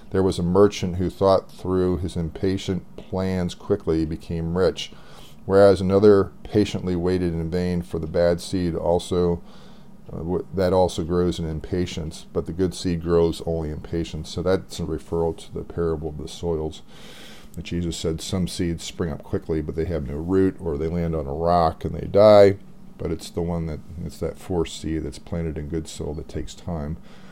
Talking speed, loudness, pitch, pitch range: 195 wpm, -23 LUFS, 85 Hz, 80-95 Hz